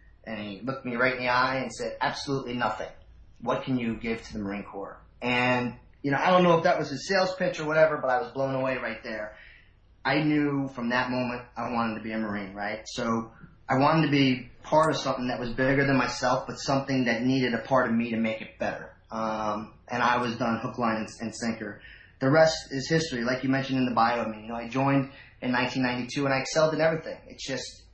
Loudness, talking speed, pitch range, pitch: -27 LUFS, 245 wpm, 110-135 Hz, 125 Hz